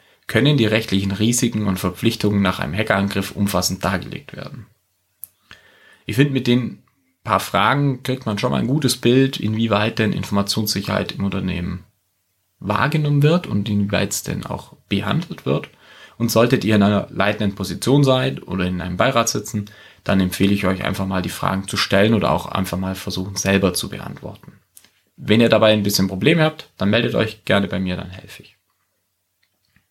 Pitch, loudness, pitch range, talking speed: 100 Hz, -19 LUFS, 95-115 Hz, 175 wpm